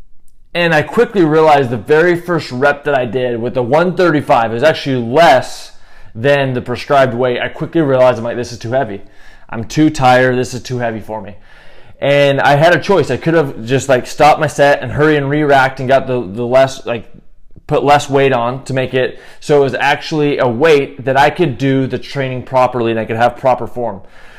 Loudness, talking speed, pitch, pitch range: -13 LUFS, 215 wpm, 130 Hz, 120-145 Hz